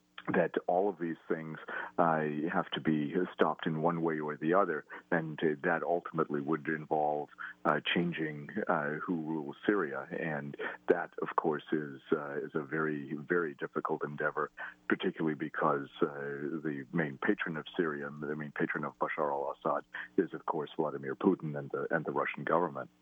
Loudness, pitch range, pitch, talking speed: -34 LUFS, 75-80 Hz, 75 Hz, 170 wpm